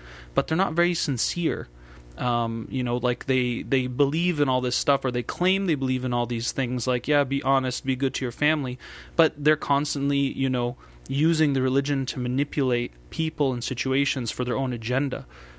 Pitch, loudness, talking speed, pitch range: 135 Hz, -25 LUFS, 195 wpm, 125-145 Hz